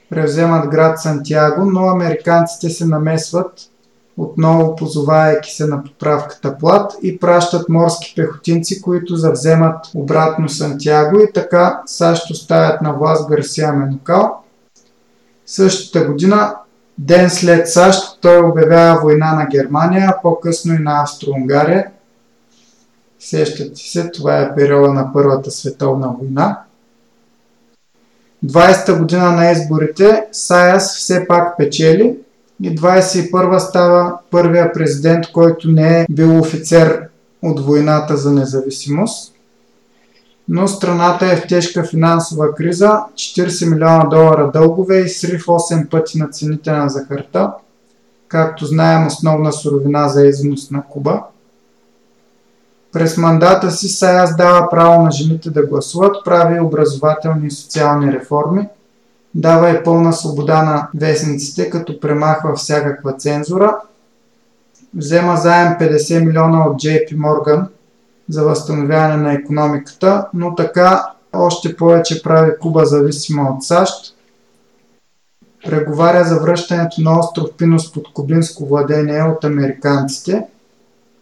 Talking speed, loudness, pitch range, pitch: 115 wpm, -13 LUFS, 150-175 Hz, 160 Hz